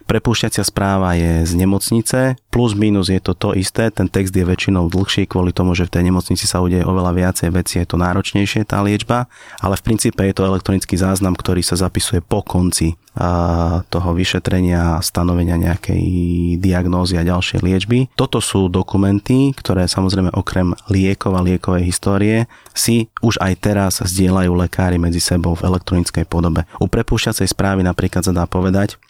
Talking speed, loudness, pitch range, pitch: 165 wpm, -16 LUFS, 90-100 Hz, 95 Hz